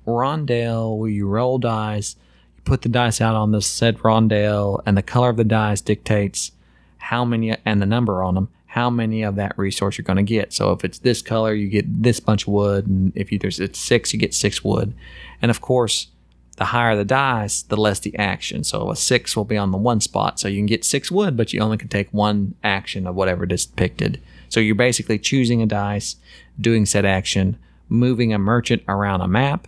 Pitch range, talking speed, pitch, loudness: 100-115 Hz, 225 wpm, 105 Hz, -20 LUFS